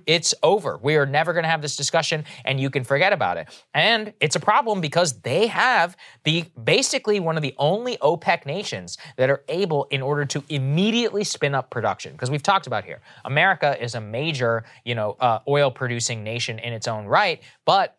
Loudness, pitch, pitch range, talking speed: -22 LUFS, 150 Hz, 130-170 Hz, 205 wpm